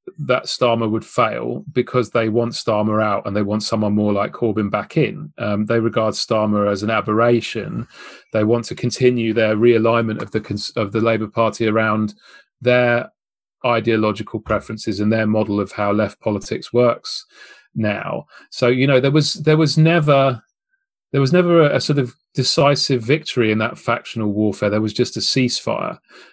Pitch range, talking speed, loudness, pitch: 110-125 Hz, 175 wpm, -18 LUFS, 115 Hz